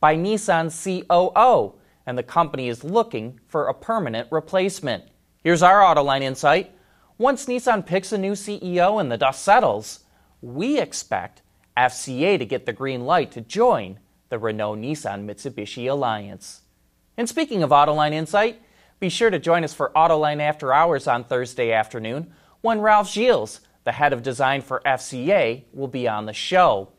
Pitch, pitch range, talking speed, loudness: 150 Hz, 120-190 Hz, 160 wpm, -21 LUFS